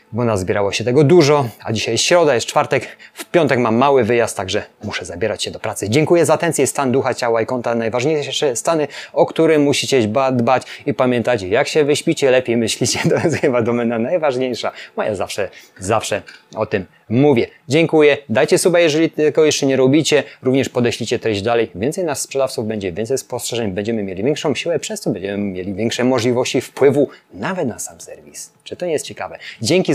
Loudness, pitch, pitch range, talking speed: -17 LUFS, 130 Hz, 115-150 Hz, 190 wpm